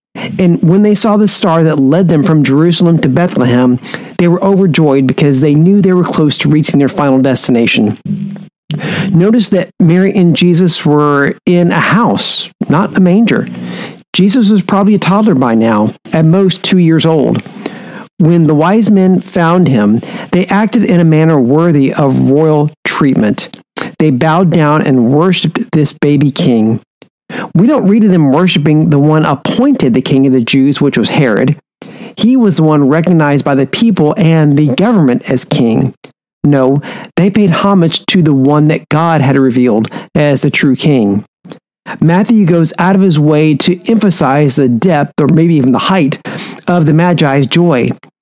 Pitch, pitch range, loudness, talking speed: 165 Hz, 145-190 Hz, -9 LUFS, 170 wpm